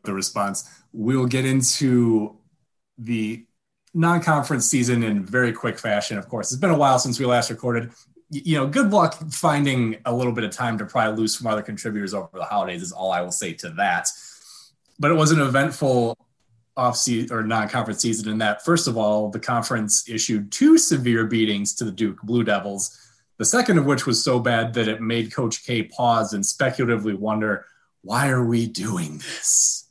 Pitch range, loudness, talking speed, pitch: 110-130 Hz, -21 LUFS, 190 wpm, 120 Hz